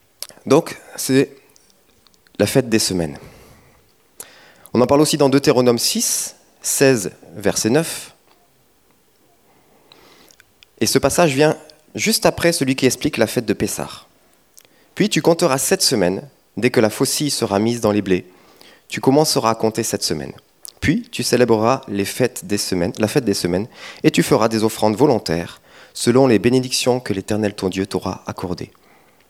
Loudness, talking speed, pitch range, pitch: -18 LUFS, 155 wpm, 100-140 Hz, 120 Hz